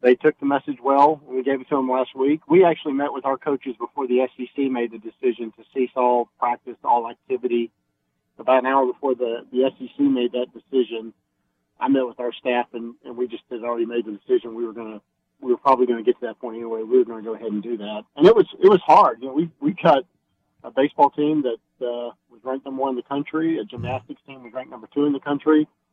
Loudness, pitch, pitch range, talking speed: -21 LUFS, 130 Hz, 120-140 Hz, 255 wpm